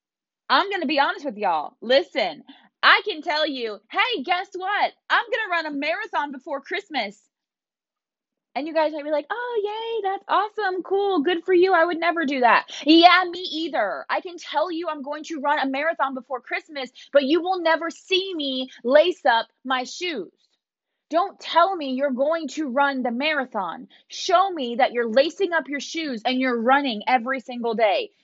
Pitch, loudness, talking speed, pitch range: 310 Hz, -22 LUFS, 190 wpm, 270-360 Hz